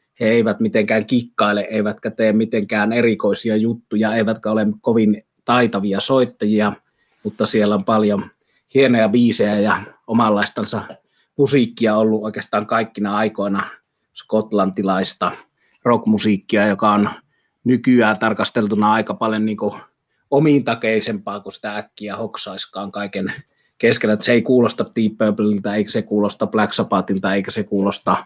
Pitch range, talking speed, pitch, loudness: 105-115 Hz, 120 wpm, 110 Hz, -18 LUFS